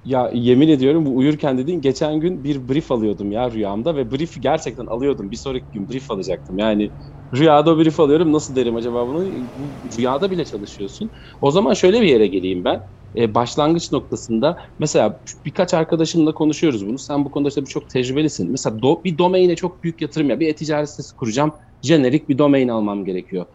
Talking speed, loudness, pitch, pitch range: 185 wpm, -19 LUFS, 140 Hz, 120-155 Hz